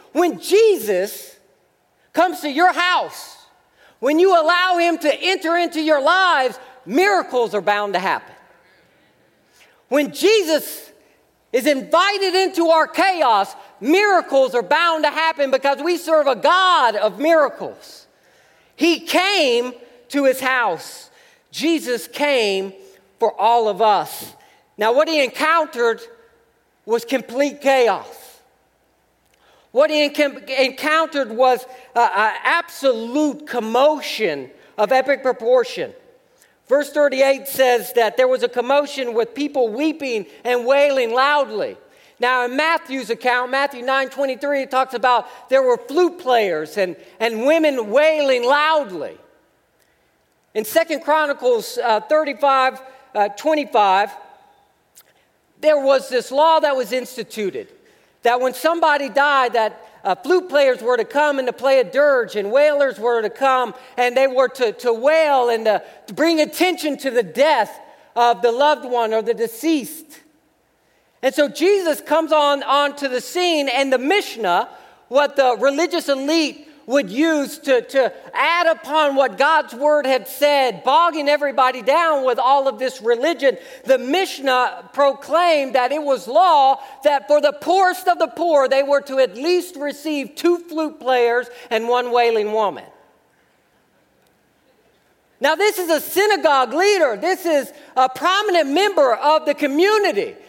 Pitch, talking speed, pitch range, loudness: 280 Hz, 140 wpm, 255-320 Hz, -18 LUFS